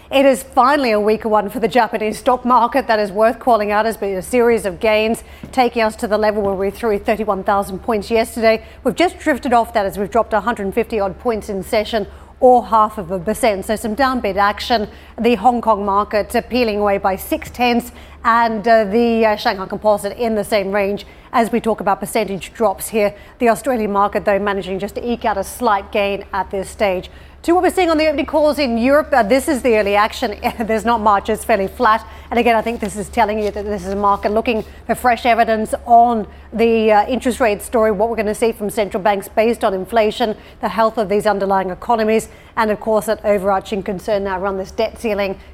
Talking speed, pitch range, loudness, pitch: 225 wpm, 205-235 Hz, -17 LUFS, 220 Hz